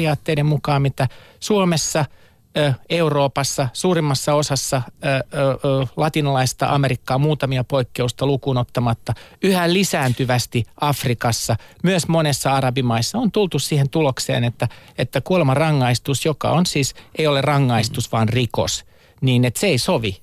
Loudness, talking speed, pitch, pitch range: -19 LUFS, 110 wpm, 135 Hz, 125-150 Hz